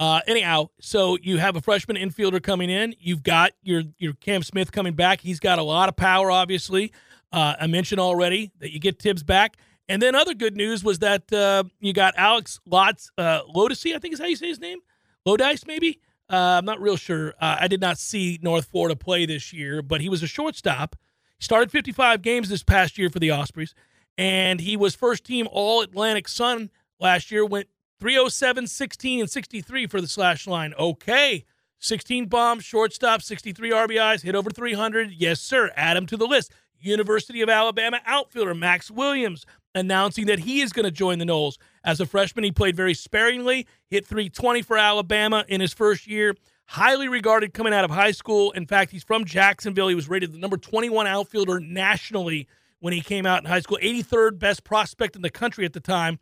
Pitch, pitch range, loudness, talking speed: 200 Hz, 180-225 Hz, -22 LUFS, 200 wpm